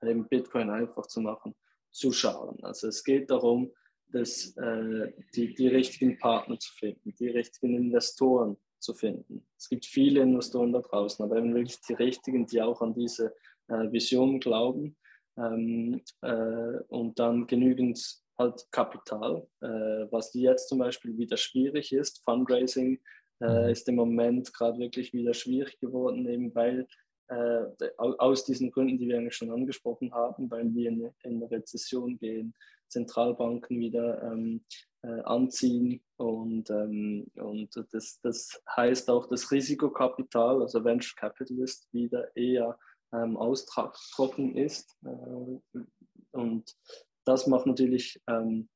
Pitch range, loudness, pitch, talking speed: 115-130 Hz, -30 LUFS, 120 Hz, 140 wpm